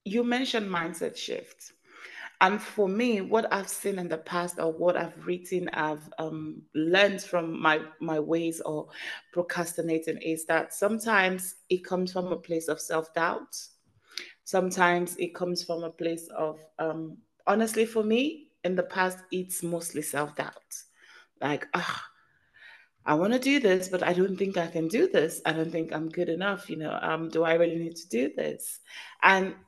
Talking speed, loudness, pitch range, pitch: 170 wpm, -28 LUFS, 165-195 Hz, 175 Hz